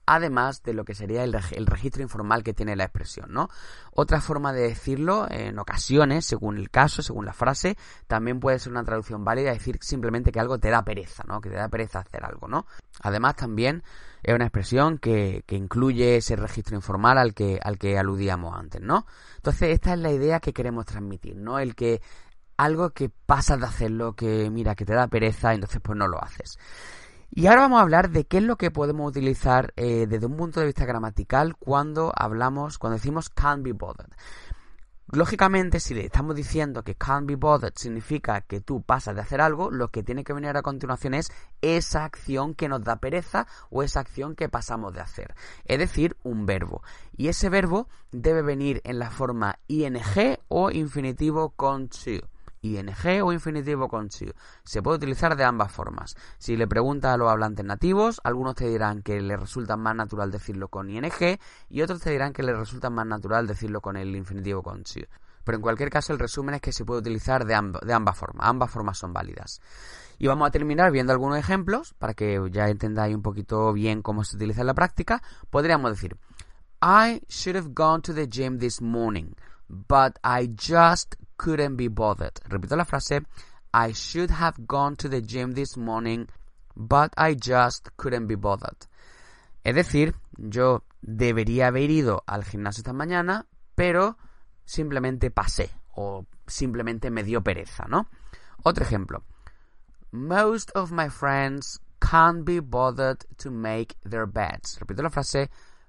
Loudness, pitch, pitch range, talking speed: -25 LUFS, 120 Hz, 105-145 Hz, 185 wpm